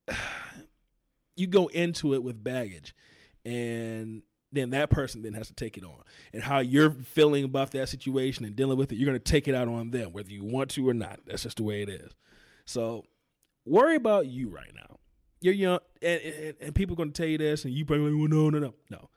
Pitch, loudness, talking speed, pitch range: 135 Hz, -28 LUFS, 230 wpm, 115-150 Hz